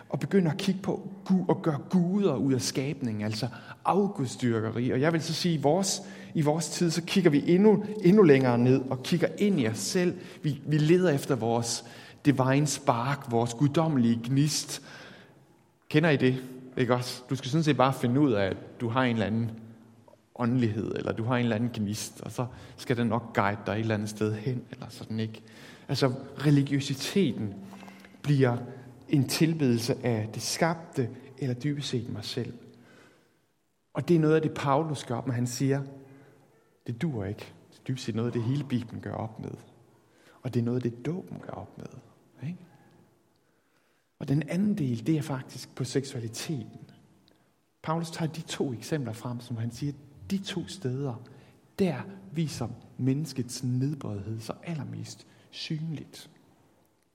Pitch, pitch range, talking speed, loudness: 135 Hz, 120-155 Hz, 175 wpm, -28 LUFS